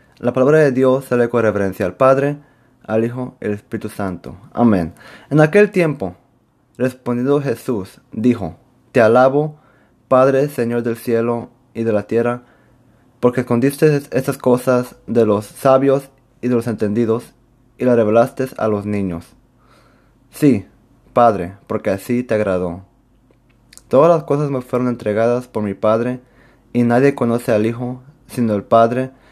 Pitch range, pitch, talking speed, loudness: 110-130 Hz, 120 Hz, 145 wpm, -17 LUFS